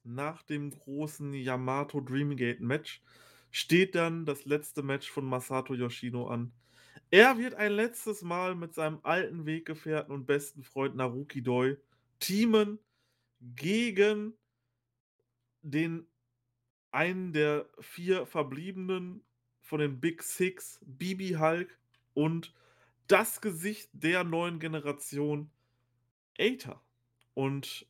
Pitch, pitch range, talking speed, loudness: 145 Hz, 125-170 Hz, 110 wpm, -31 LUFS